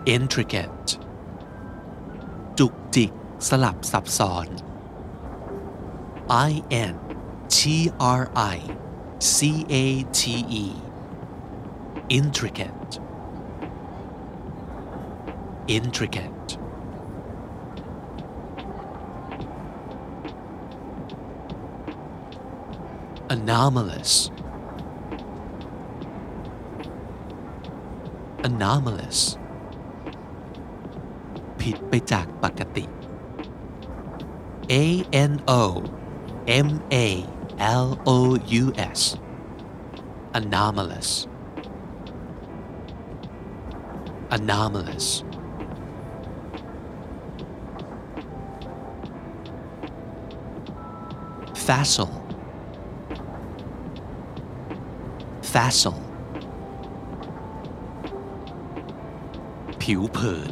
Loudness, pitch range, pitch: -25 LUFS, 100-130 Hz, 115 Hz